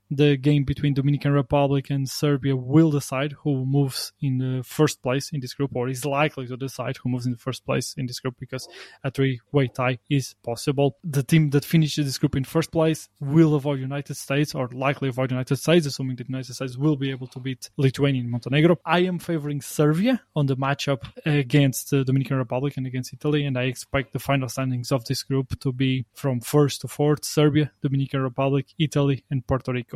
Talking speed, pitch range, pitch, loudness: 210 wpm, 130-145 Hz, 140 Hz, -24 LUFS